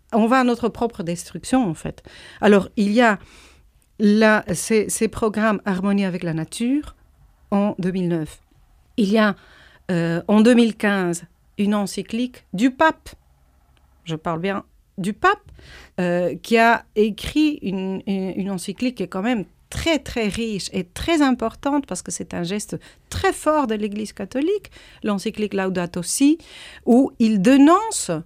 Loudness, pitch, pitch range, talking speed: -20 LUFS, 210 Hz, 185-235 Hz, 150 wpm